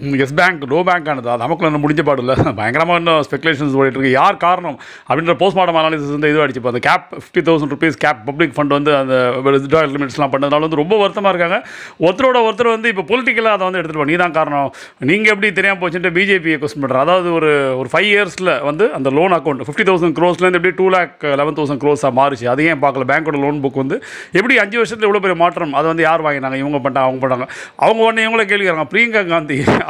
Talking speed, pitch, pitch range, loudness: 205 wpm, 160 Hz, 140-185 Hz, -14 LUFS